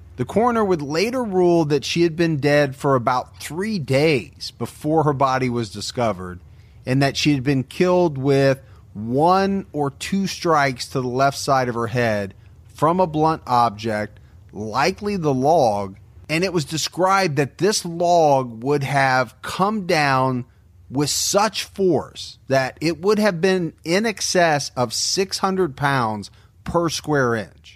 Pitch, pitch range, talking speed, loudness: 140 Hz, 115-175 Hz, 155 wpm, -20 LUFS